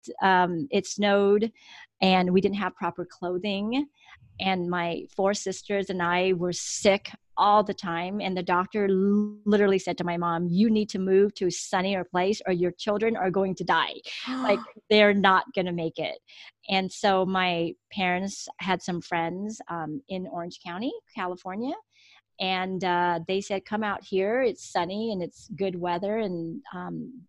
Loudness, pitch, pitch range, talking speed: -26 LUFS, 190 Hz, 180-205 Hz, 170 wpm